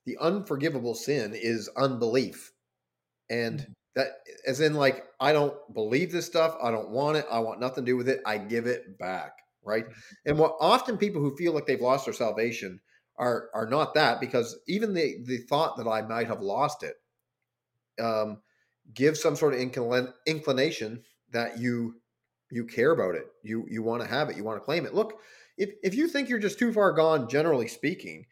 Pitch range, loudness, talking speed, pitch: 115-155 Hz, -28 LUFS, 195 wpm, 125 Hz